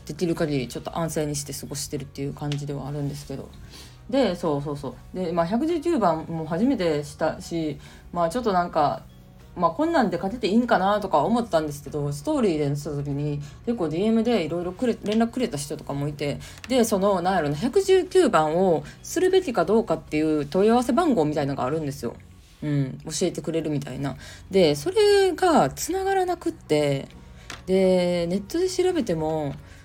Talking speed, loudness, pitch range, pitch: 380 characters per minute, -24 LUFS, 145-230 Hz, 165 Hz